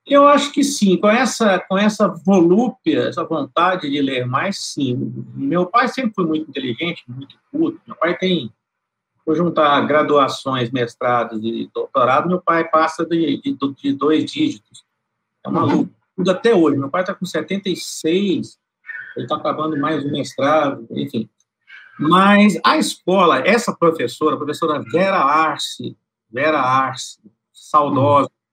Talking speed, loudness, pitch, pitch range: 145 wpm, -17 LUFS, 170 Hz, 145-210 Hz